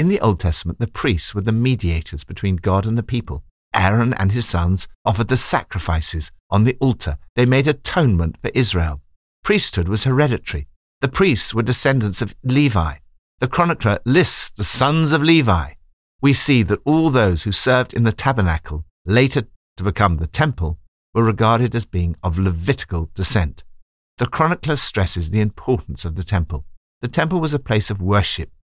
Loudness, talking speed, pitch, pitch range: -18 LUFS, 170 wpm, 105 Hz, 85-125 Hz